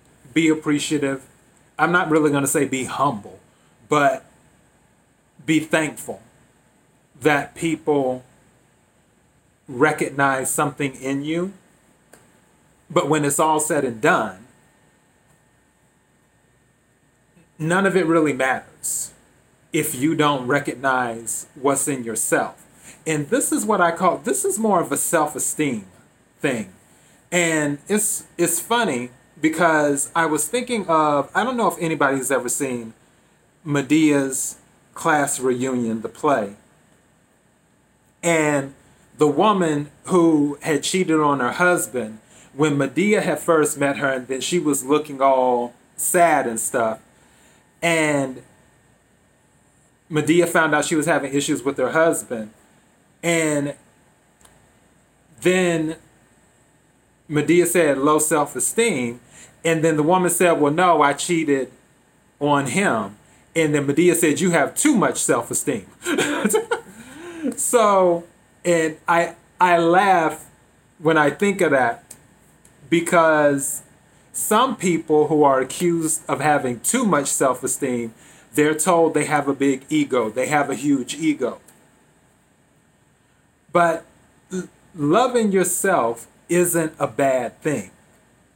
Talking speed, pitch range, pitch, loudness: 120 wpm, 140-170 Hz, 150 Hz, -20 LUFS